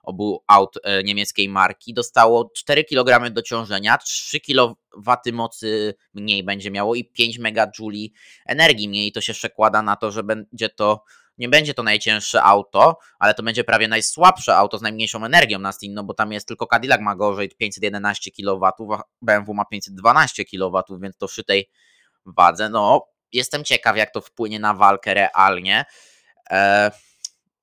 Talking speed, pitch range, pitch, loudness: 155 wpm, 100-115 Hz, 105 Hz, -18 LUFS